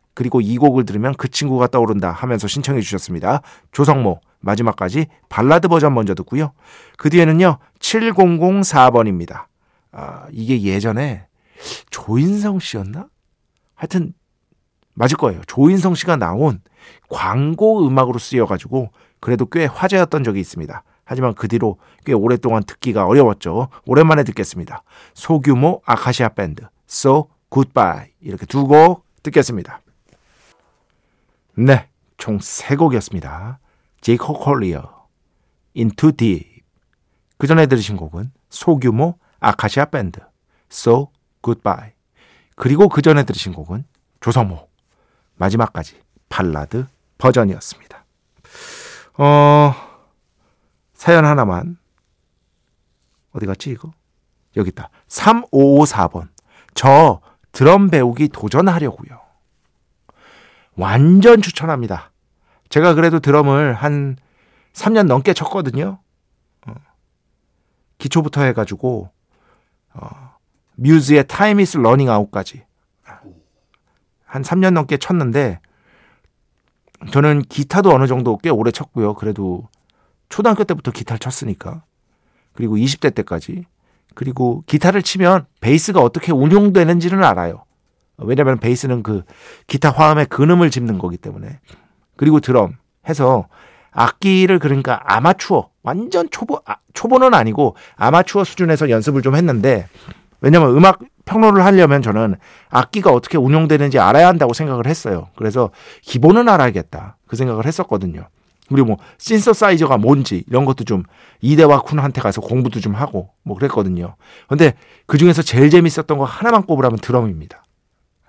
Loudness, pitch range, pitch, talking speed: -15 LUFS, 105-155 Hz, 130 Hz, 290 characters per minute